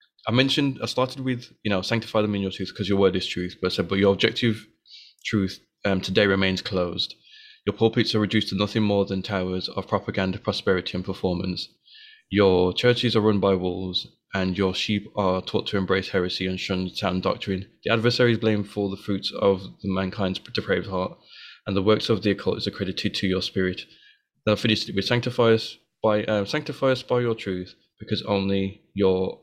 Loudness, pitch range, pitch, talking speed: -24 LUFS, 95-110 Hz, 100 Hz, 200 wpm